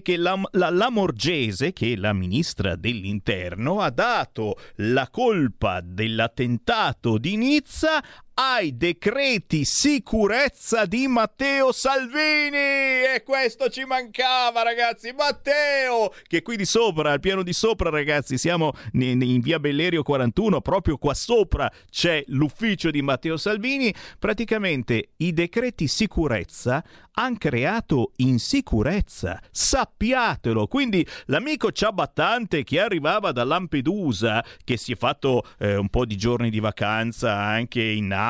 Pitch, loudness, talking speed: 170 Hz, -23 LUFS, 125 wpm